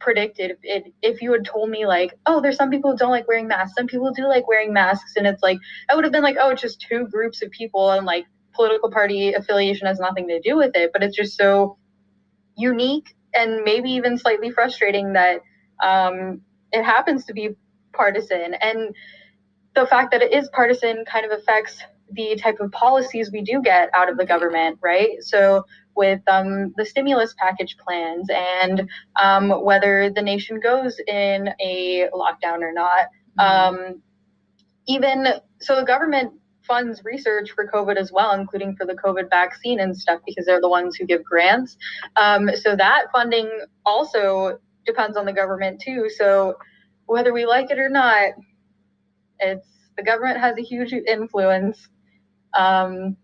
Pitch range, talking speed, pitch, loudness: 185-235 Hz, 175 wpm, 205 Hz, -19 LUFS